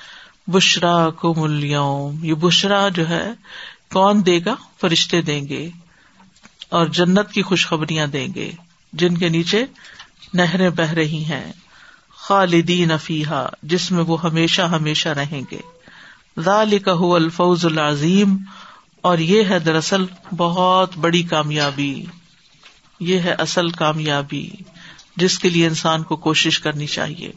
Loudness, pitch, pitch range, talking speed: -18 LUFS, 170 Hz, 160-185 Hz, 125 wpm